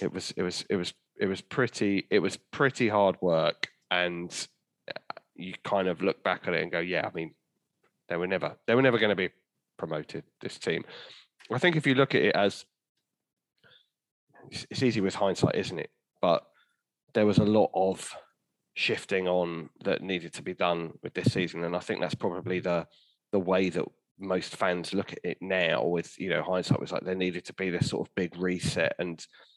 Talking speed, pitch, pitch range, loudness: 205 wpm, 90 Hz, 85-95 Hz, -29 LUFS